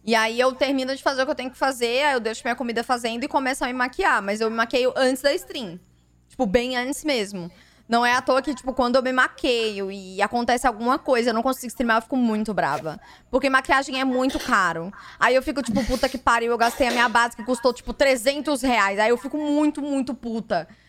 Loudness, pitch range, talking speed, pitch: -22 LUFS, 230-270 Hz, 240 wpm, 255 Hz